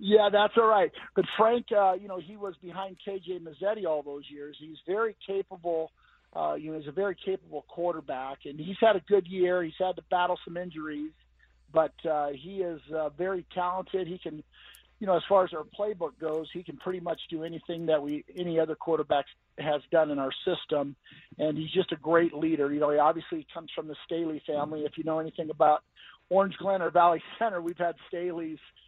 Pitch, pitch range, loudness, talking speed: 170 Hz, 155-185 Hz, -29 LUFS, 210 wpm